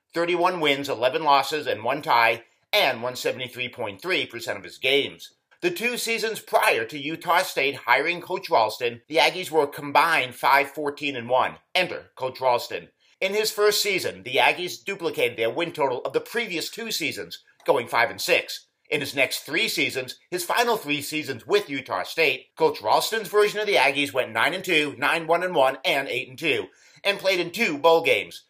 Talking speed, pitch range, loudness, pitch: 160 wpm, 140-215 Hz, -23 LUFS, 170 Hz